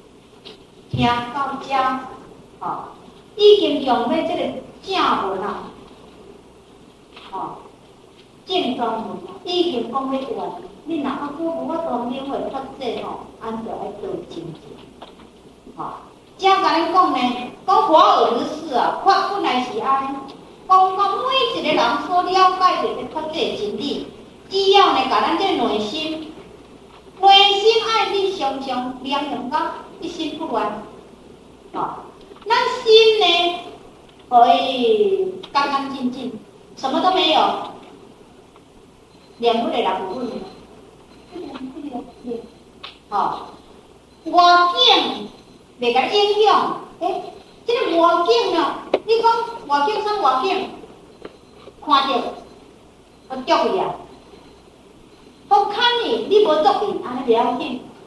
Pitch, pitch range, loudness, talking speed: 330 Hz, 260-390 Hz, -18 LUFS, 165 characters per minute